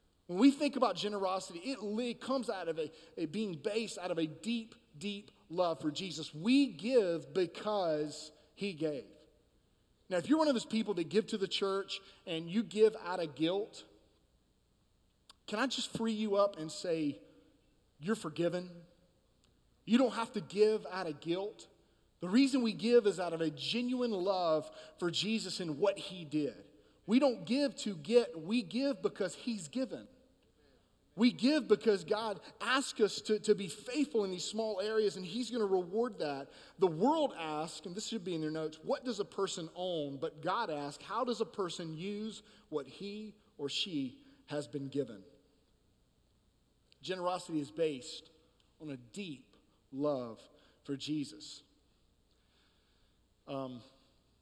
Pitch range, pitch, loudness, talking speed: 155-225 Hz, 195 Hz, -35 LUFS, 165 wpm